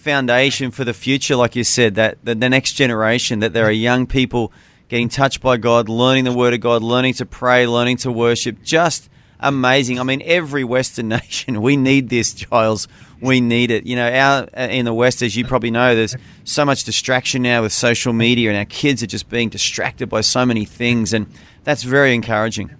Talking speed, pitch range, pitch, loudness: 205 wpm, 115-130 Hz, 125 Hz, -16 LUFS